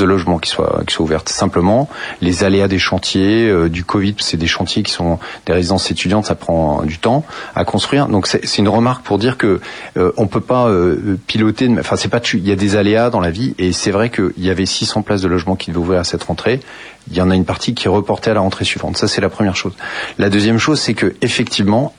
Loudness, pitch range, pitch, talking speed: -15 LUFS, 90-110 Hz, 100 Hz, 260 wpm